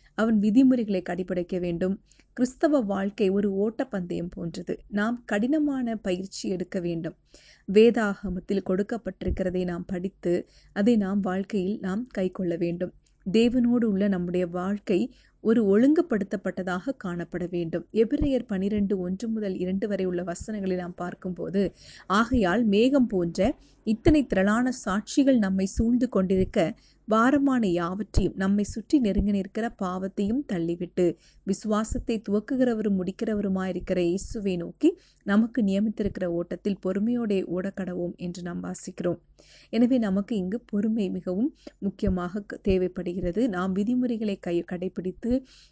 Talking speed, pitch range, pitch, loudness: 110 wpm, 185-225 Hz, 200 Hz, -26 LUFS